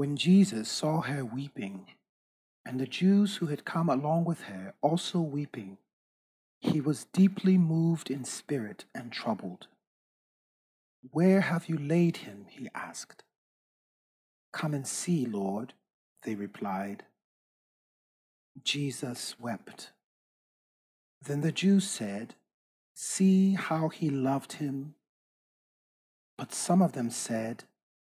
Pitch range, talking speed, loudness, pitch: 110-170 Hz, 115 wpm, -30 LUFS, 145 Hz